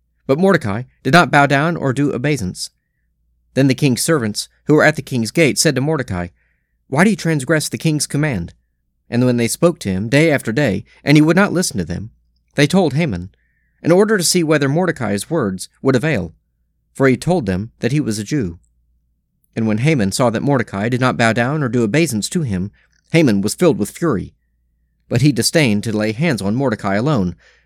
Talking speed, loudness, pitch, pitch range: 205 wpm, -16 LUFS, 120 Hz, 95-155 Hz